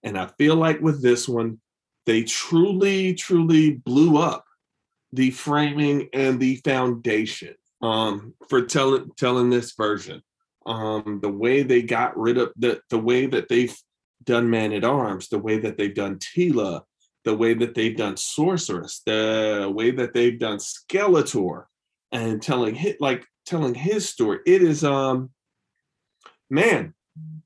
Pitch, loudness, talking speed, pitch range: 125 Hz, -22 LUFS, 145 wpm, 110-150 Hz